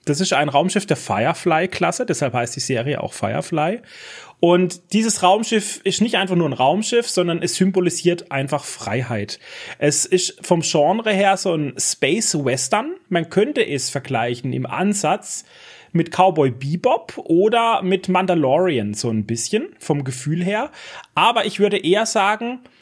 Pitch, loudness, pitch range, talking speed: 180 Hz, -19 LUFS, 145-200 Hz, 155 wpm